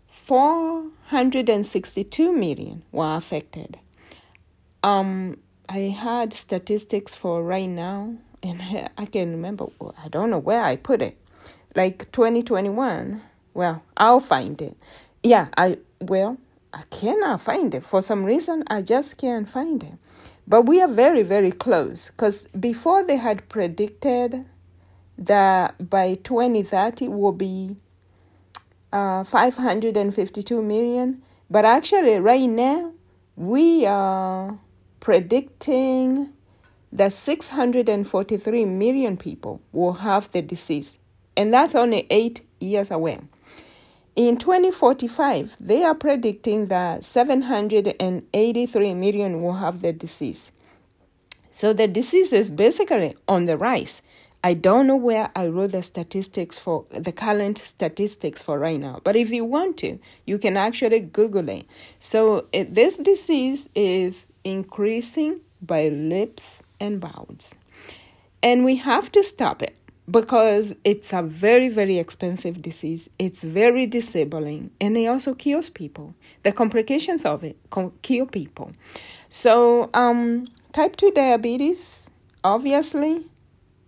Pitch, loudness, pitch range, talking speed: 210 Hz, -21 LUFS, 185-250 Hz, 125 wpm